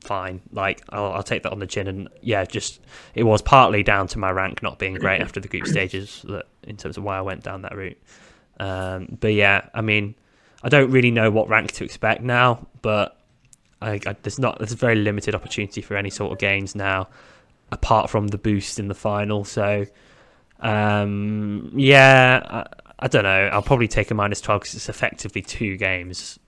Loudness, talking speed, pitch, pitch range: -20 LUFS, 205 wpm, 105 Hz, 95-110 Hz